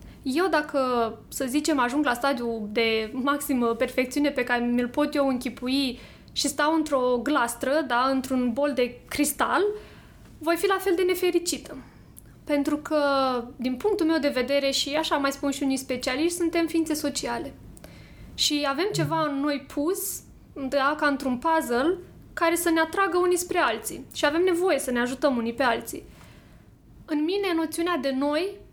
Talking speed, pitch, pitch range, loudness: 165 wpm, 290 Hz, 260-325 Hz, -25 LUFS